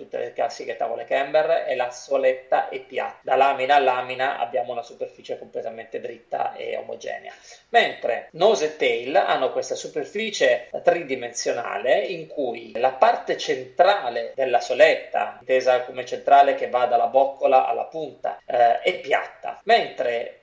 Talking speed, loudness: 140 wpm, -22 LUFS